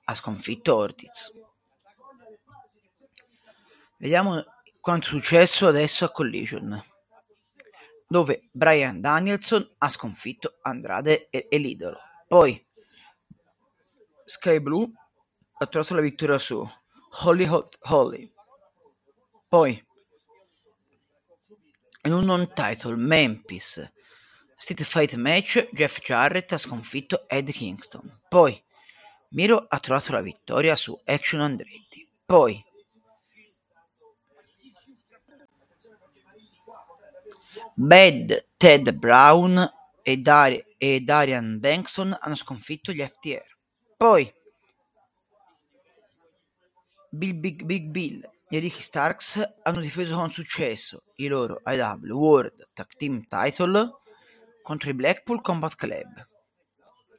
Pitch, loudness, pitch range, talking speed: 180 Hz, -22 LUFS, 150-230 Hz, 95 wpm